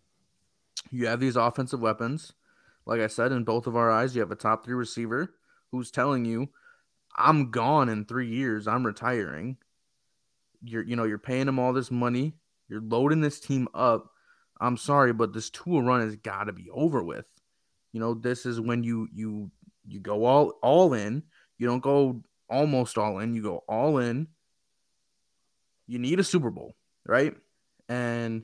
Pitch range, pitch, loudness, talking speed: 115-130 Hz, 120 Hz, -27 LUFS, 175 wpm